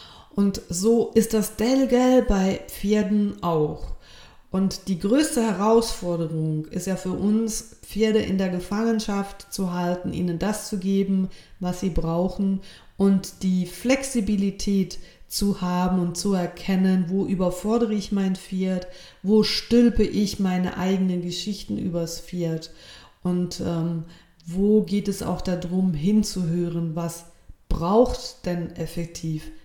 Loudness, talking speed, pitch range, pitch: -24 LUFS, 125 wpm, 175-210 Hz, 190 Hz